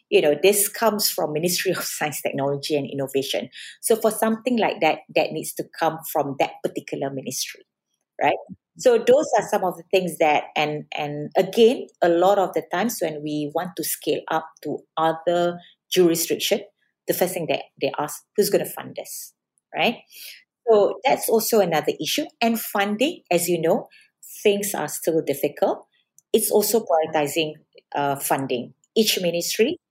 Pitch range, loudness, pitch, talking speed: 155-210 Hz, -22 LUFS, 175 Hz, 165 wpm